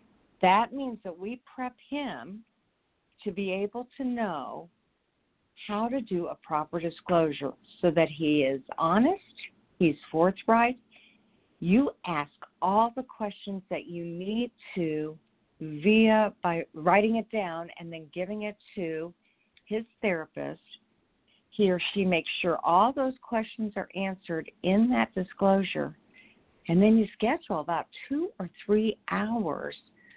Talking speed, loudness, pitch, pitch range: 135 wpm, -28 LUFS, 200 Hz, 170-225 Hz